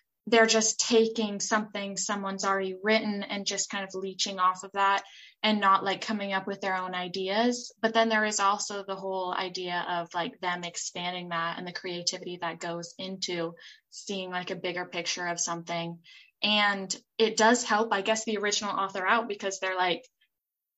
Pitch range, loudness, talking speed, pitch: 180-215 Hz, -28 LUFS, 180 wpm, 195 Hz